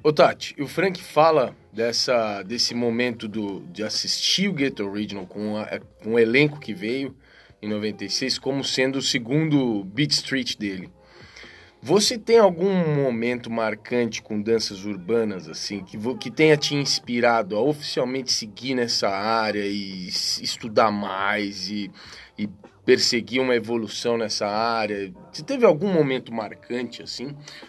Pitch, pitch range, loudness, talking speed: 120 Hz, 105-135 Hz, -23 LUFS, 140 wpm